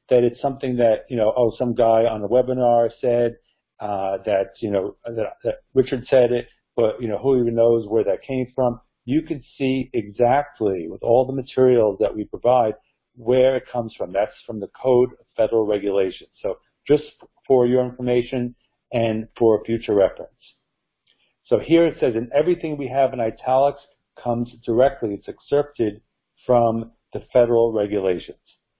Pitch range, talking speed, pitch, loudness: 115-130 Hz, 170 wpm, 120 Hz, -21 LUFS